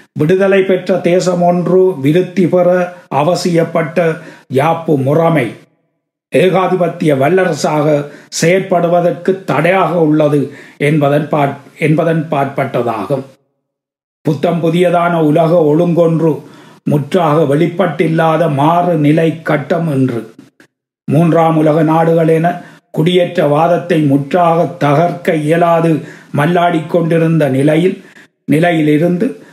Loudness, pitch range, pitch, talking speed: -12 LUFS, 150-175 Hz, 165 Hz, 75 wpm